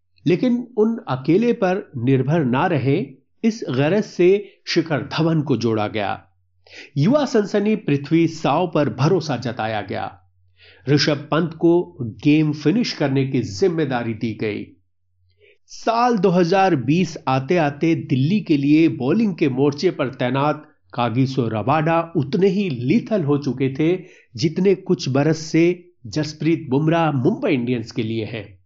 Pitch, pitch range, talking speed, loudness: 150 Hz, 125-175 Hz, 135 wpm, -20 LUFS